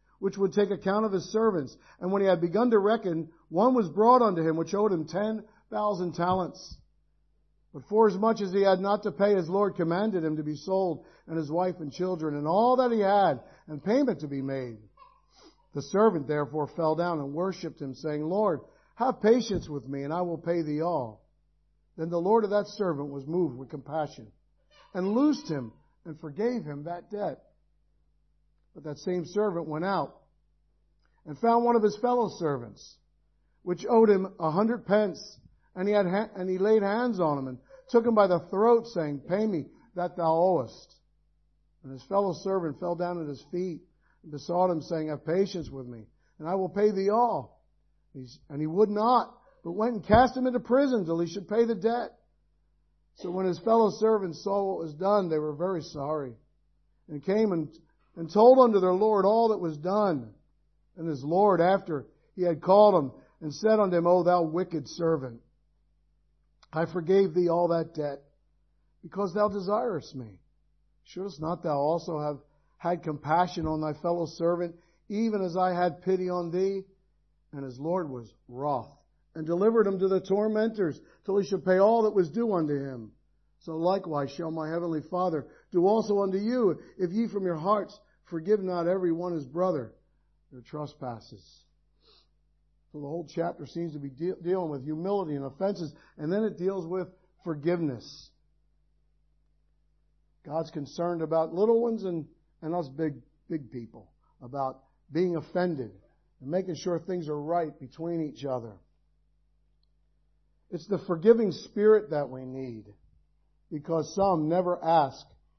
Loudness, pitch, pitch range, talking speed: -28 LUFS, 175 Hz, 150-200 Hz, 180 wpm